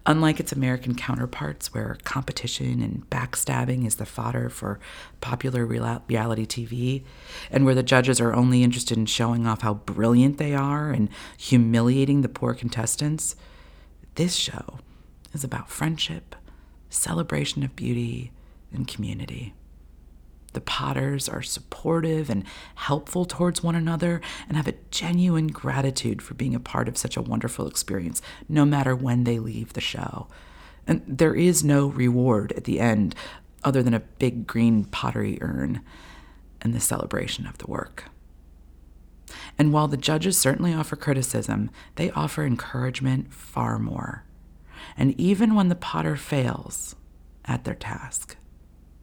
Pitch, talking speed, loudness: 120 Hz, 140 wpm, -25 LUFS